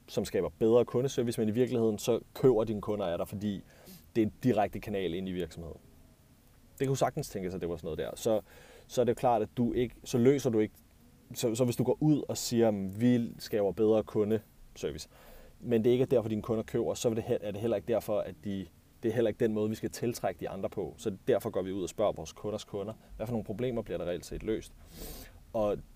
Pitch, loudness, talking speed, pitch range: 110 Hz, -32 LUFS, 245 wpm, 105-120 Hz